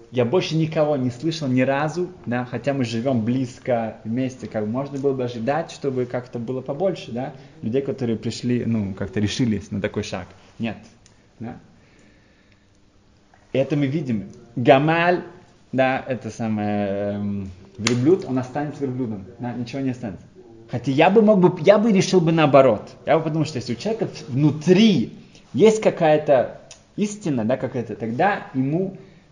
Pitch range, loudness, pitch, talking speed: 110-150 Hz, -21 LUFS, 125 Hz, 160 wpm